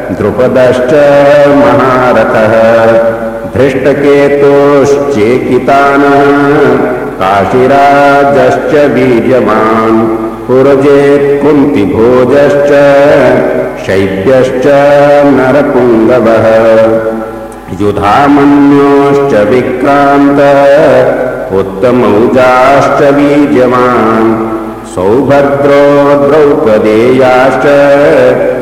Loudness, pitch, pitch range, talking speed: -5 LUFS, 130 Hz, 110-140 Hz, 30 wpm